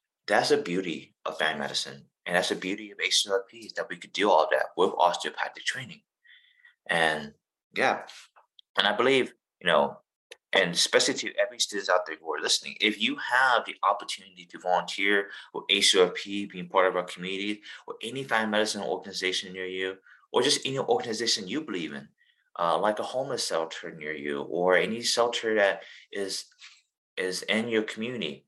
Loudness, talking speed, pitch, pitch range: -27 LUFS, 175 wpm, 100 Hz, 95-120 Hz